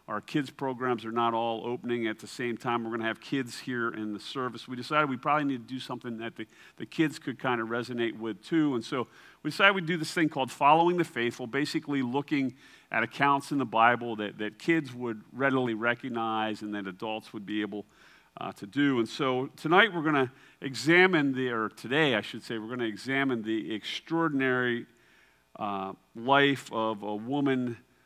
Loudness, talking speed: -29 LUFS, 200 wpm